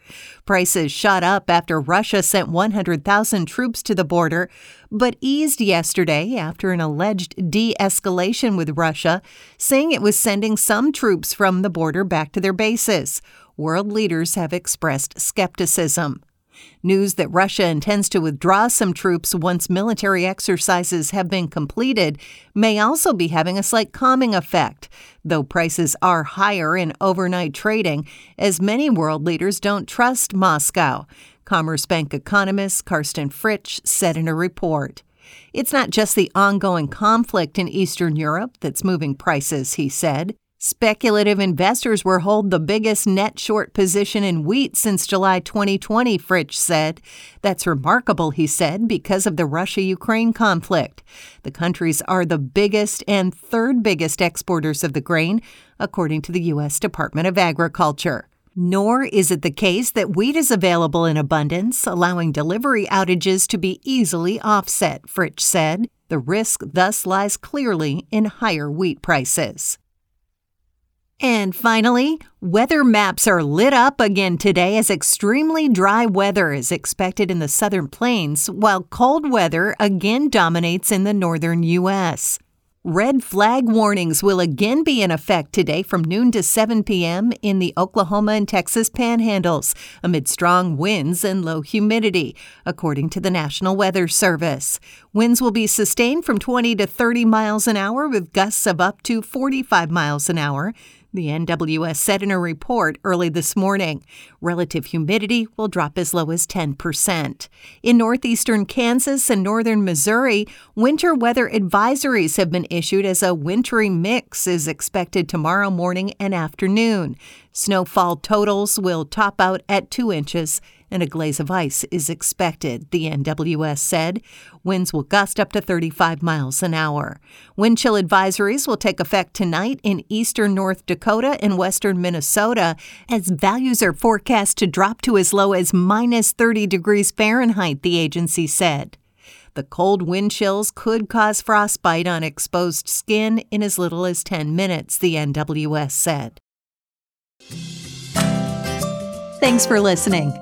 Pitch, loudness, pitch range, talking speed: 190 Hz, -18 LUFS, 170-215 Hz, 150 wpm